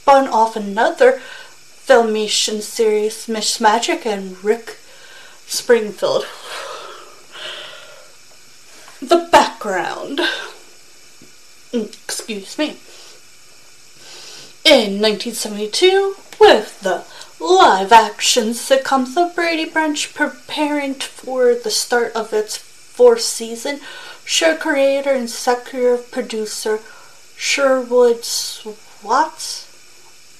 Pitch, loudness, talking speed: 275 Hz, -16 LUFS, 75 wpm